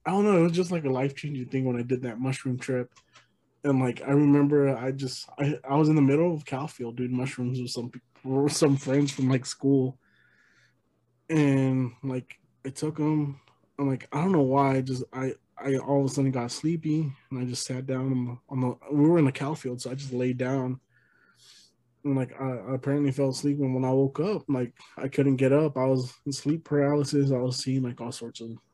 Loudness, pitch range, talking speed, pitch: -27 LUFS, 130-145 Hz, 235 wpm, 135 Hz